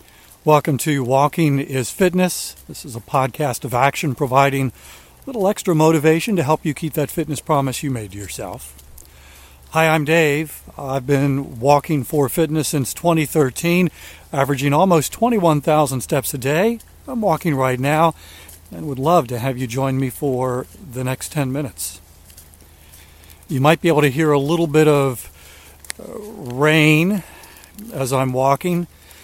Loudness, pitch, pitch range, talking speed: -18 LUFS, 145 Hz, 130-160 Hz, 150 wpm